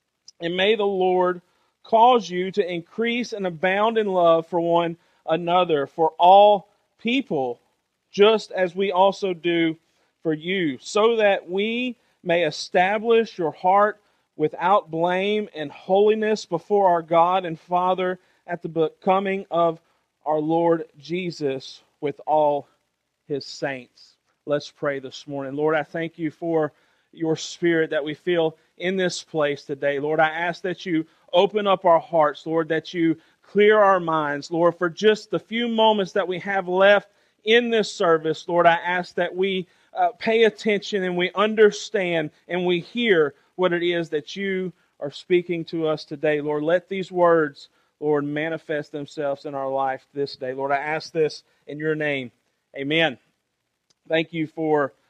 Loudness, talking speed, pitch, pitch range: -22 LUFS, 160 wpm, 170 Hz, 155-195 Hz